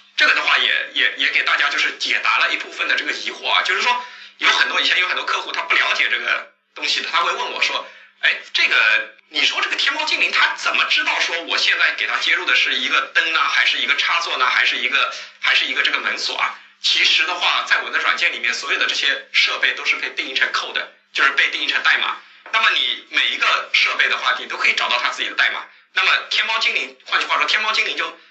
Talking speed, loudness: 370 characters per minute, -17 LUFS